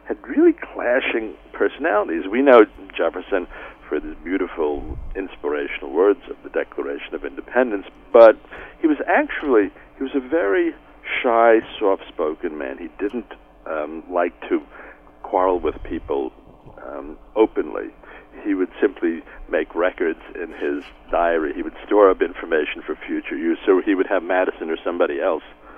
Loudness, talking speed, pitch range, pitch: -21 LUFS, 145 wpm, 315-405 Hz, 350 Hz